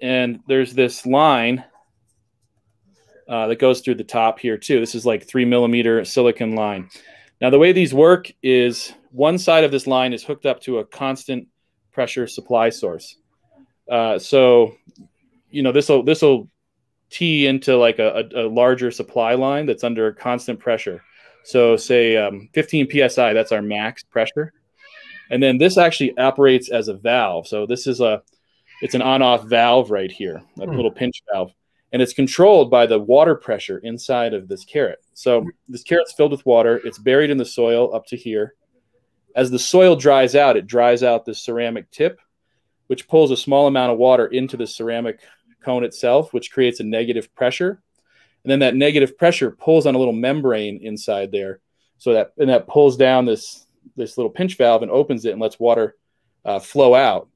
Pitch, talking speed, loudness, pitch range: 125 Hz, 185 wpm, -17 LUFS, 115-140 Hz